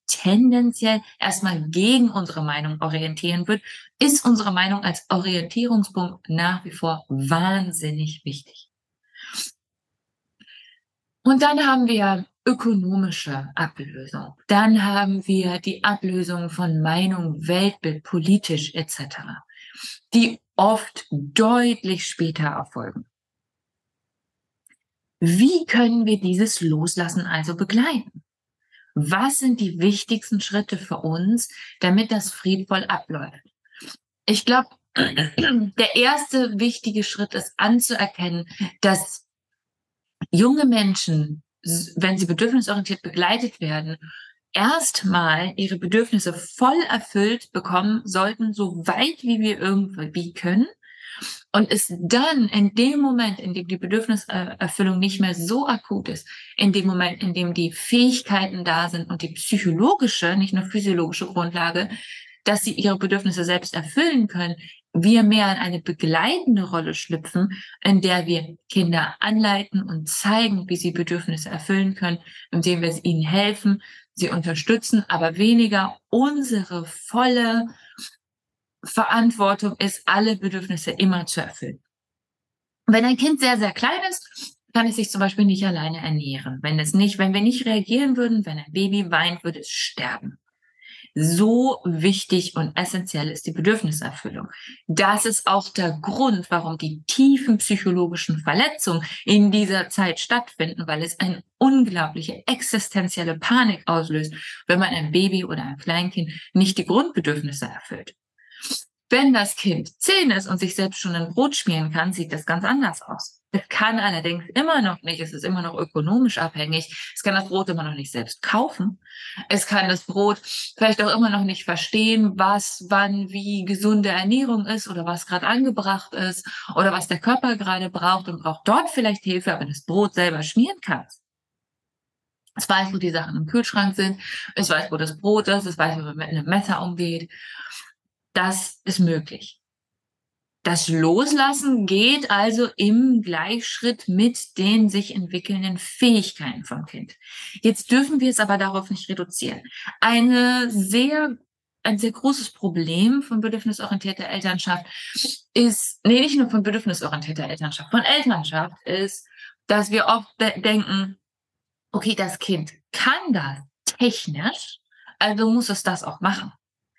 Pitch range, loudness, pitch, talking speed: 170-225 Hz, -21 LUFS, 195 Hz, 140 wpm